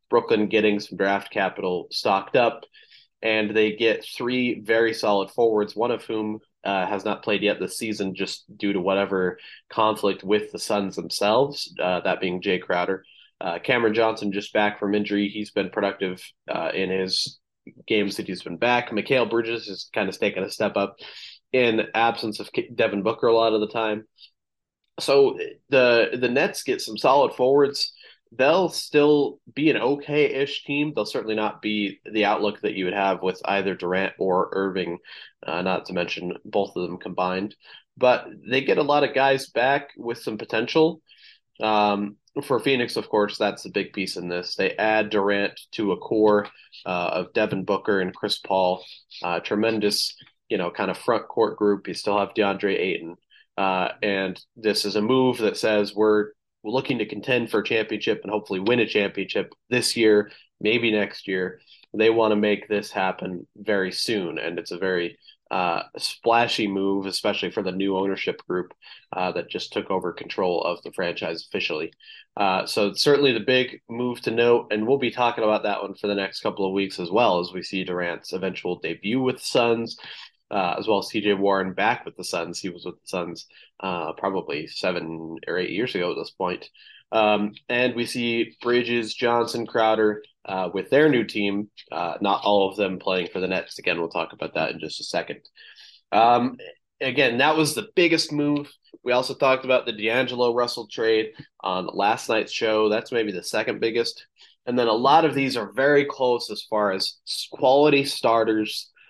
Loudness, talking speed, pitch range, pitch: -23 LUFS, 190 wpm, 100-120 Hz, 105 Hz